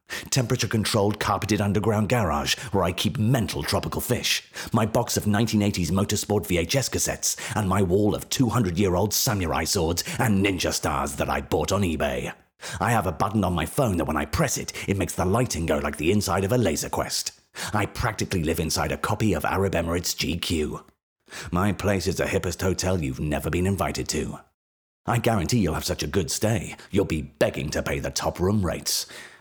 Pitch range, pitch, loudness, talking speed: 80-105 Hz, 95 Hz, -24 LUFS, 190 wpm